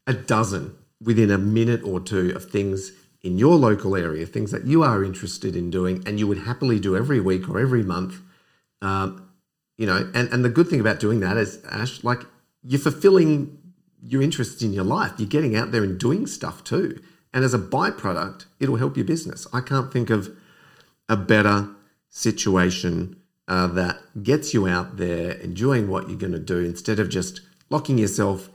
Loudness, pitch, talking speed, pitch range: -22 LUFS, 110 Hz, 190 wpm, 95-130 Hz